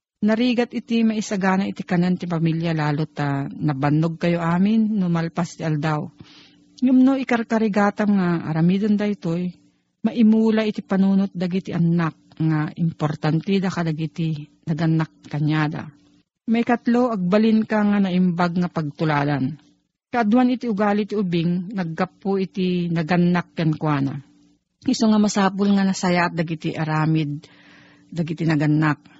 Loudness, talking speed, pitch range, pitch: -21 LUFS, 125 wpm, 160-210 Hz, 175 Hz